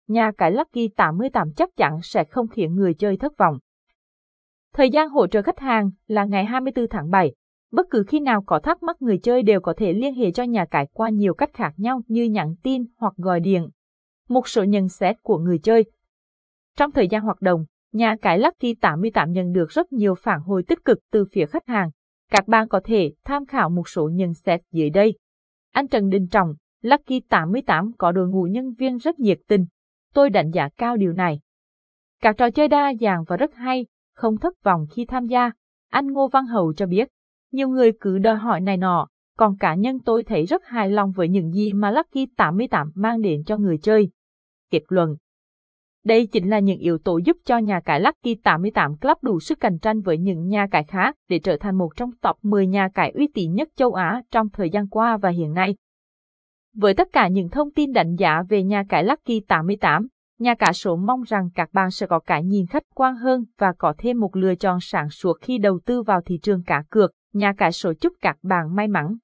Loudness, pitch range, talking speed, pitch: -21 LUFS, 185-240 Hz, 220 wpm, 210 Hz